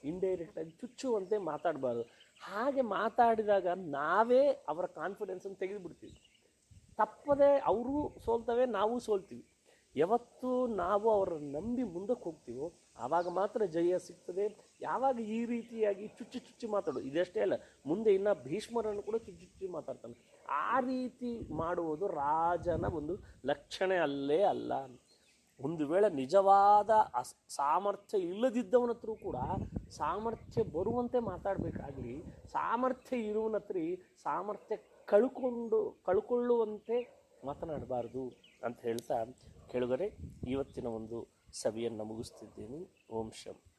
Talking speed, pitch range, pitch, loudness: 100 wpm, 165-240 Hz, 205 Hz, -34 LUFS